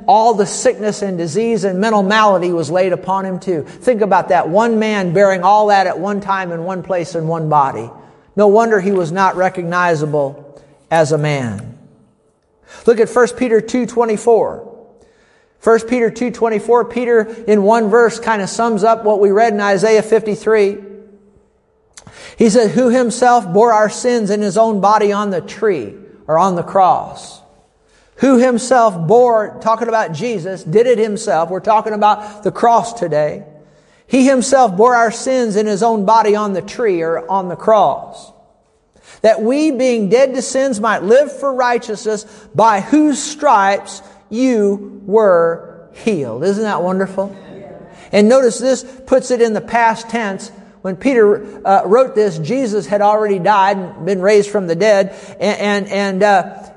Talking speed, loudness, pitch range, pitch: 165 wpm, -14 LUFS, 195-230 Hz, 210 Hz